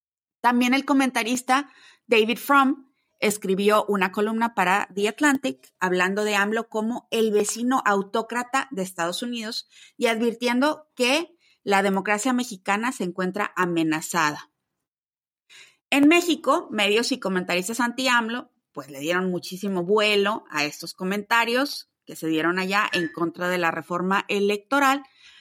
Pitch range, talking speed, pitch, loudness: 185-255 Hz, 130 wpm, 215 Hz, -23 LUFS